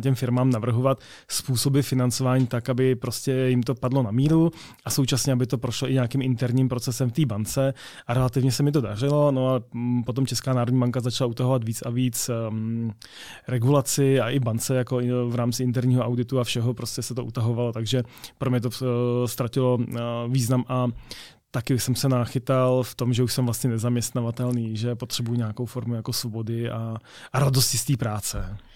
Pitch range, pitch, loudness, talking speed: 120-130 Hz, 125 Hz, -24 LUFS, 190 wpm